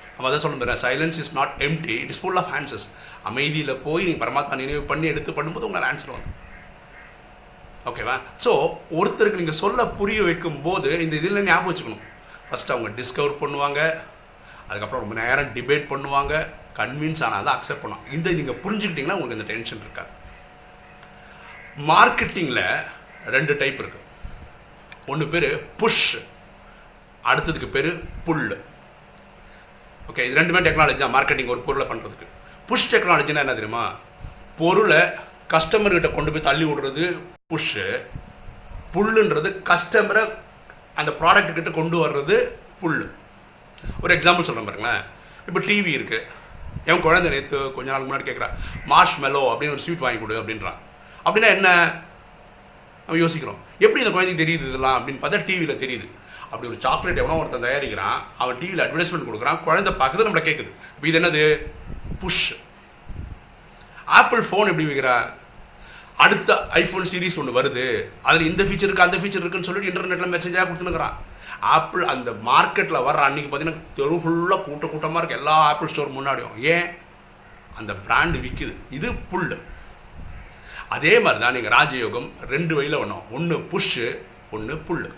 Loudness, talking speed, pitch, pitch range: -21 LUFS, 140 wpm, 165 Hz, 145-185 Hz